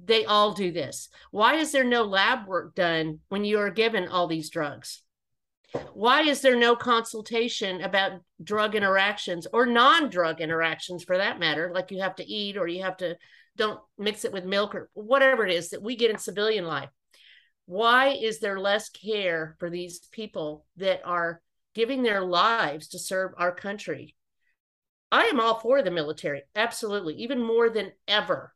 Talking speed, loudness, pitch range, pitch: 180 wpm, -25 LUFS, 180-230 Hz, 200 Hz